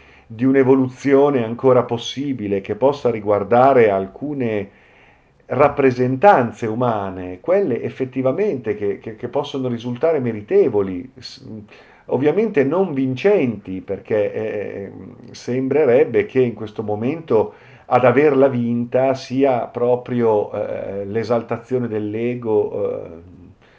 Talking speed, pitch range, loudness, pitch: 95 wpm, 110-135 Hz, -18 LUFS, 125 Hz